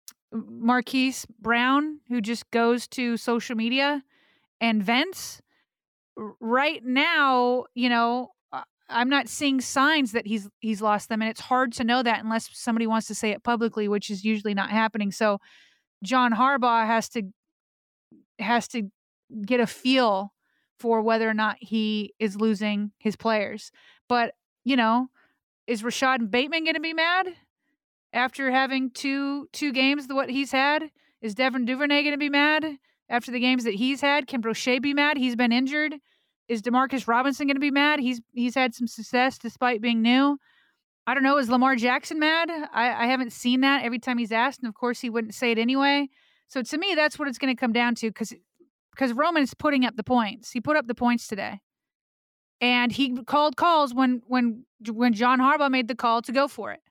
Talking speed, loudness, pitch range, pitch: 190 wpm, -24 LUFS, 230-275 Hz, 250 Hz